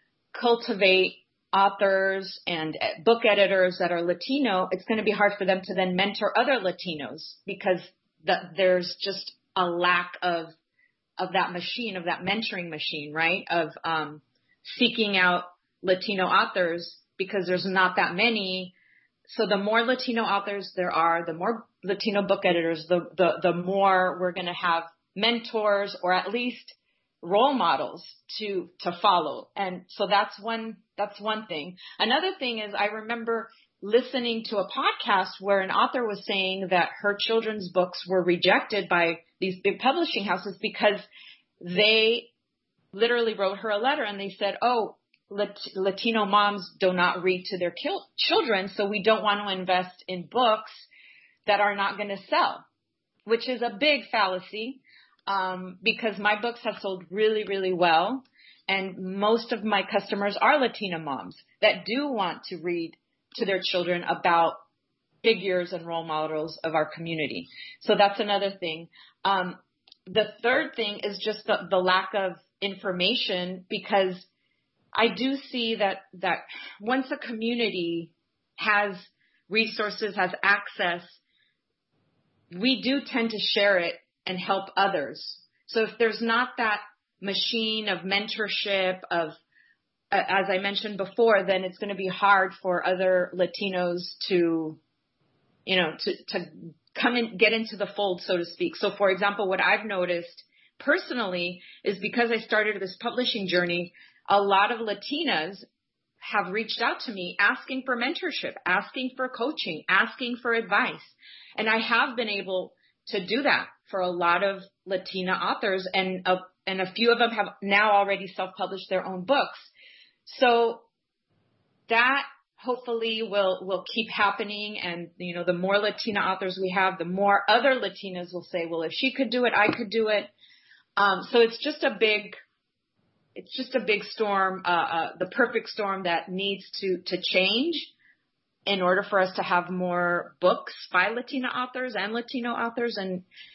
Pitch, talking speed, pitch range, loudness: 200 Hz, 160 wpm, 185-225 Hz, -26 LUFS